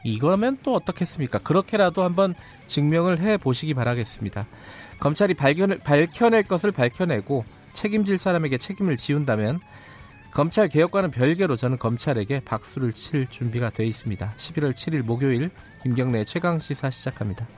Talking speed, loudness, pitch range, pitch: 360 characters per minute, -23 LUFS, 120-180 Hz, 145 Hz